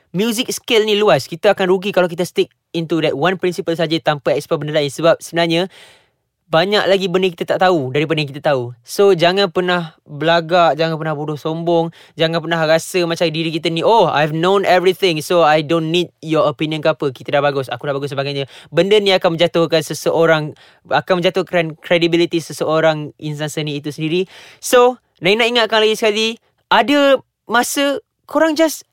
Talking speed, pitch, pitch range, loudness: 180 wpm, 170 Hz, 155-190 Hz, -16 LUFS